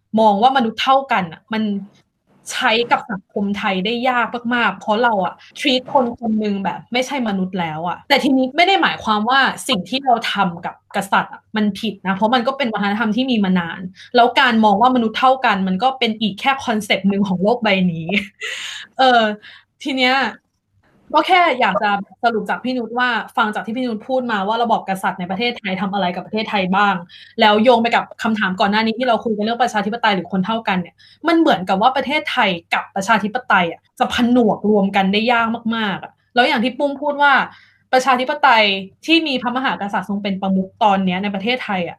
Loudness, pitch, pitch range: -17 LUFS, 220 Hz, 200-255 Hz